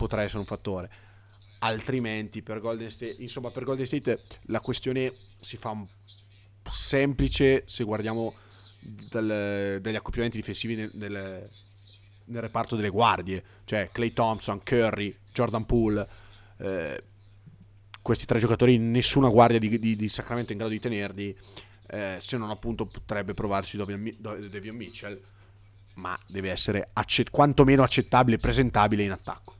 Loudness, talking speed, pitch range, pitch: -27 LUFS, 135 wpm, 100-115 Hz, 105 Hz